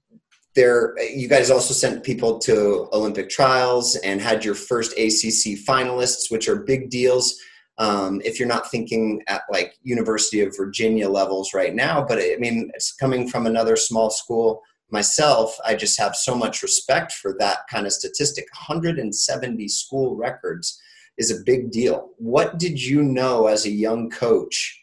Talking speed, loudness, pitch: 165 wpm, -20 LUFS, 125 Hz